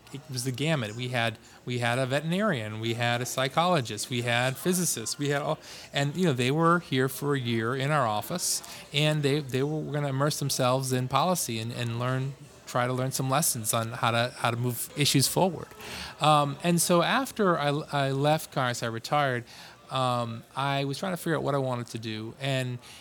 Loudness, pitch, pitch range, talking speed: -27 LUFS, 135 Hz, 120-150 Hz, 210 wpm